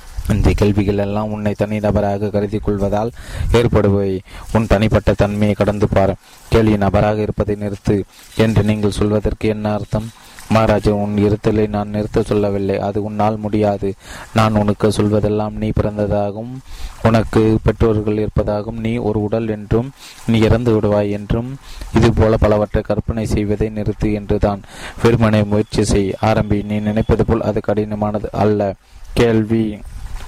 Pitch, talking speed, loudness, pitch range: 105 Hz, 130 wpm, -17 LUFS, 105-110 Hz